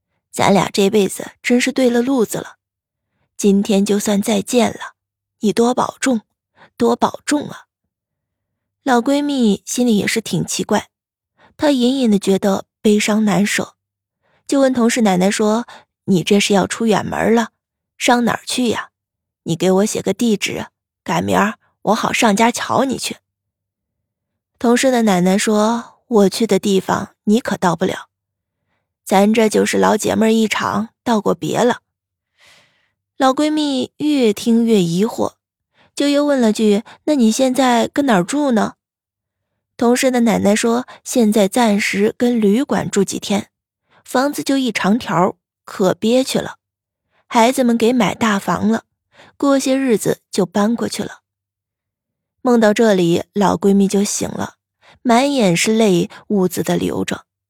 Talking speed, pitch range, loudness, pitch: 205 characters per minute, 180-240 Hz, -16 LUFS, 210 Hz